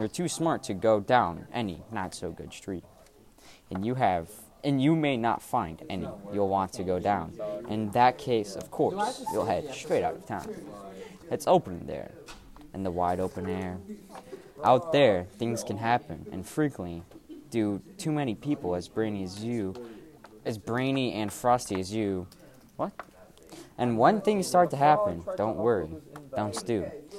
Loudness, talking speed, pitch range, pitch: -29 LUFS, 180 wpm, 95-130 Hz, 110 Hz